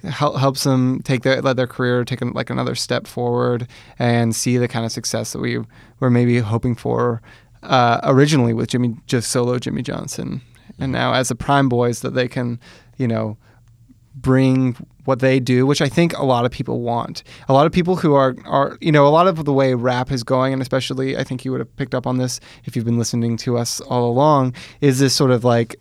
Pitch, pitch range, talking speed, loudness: 125 Hz, 120-135 Hz, 225 wpm, -18 LUFS